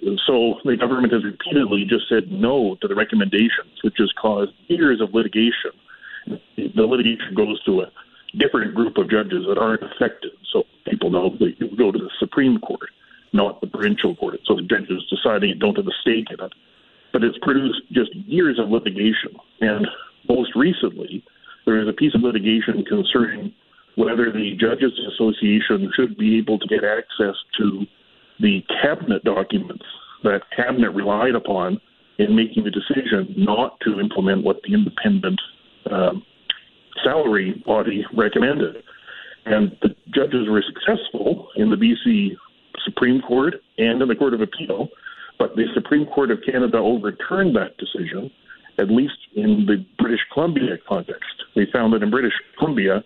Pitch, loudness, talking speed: 125 Hz, -20 LUFS, 160 wpm